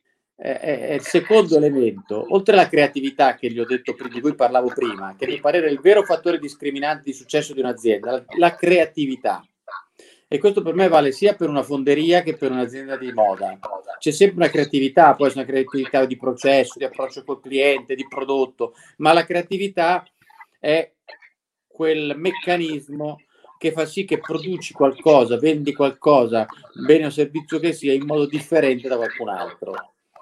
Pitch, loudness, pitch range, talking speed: 150 Hz, -19 LUFS, 135-170 Hz, 170 wpm